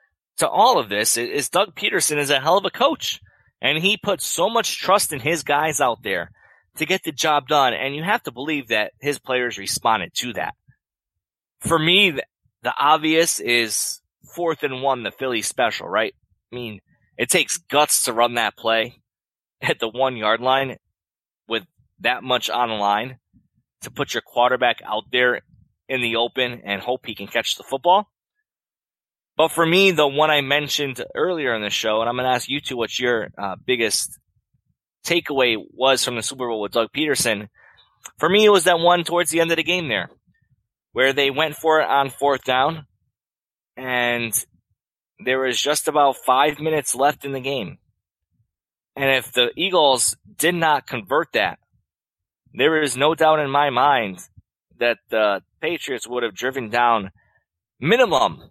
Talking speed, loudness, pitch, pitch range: 180 wpm, -20 LUFS, 130 Hz, 115-150 Hz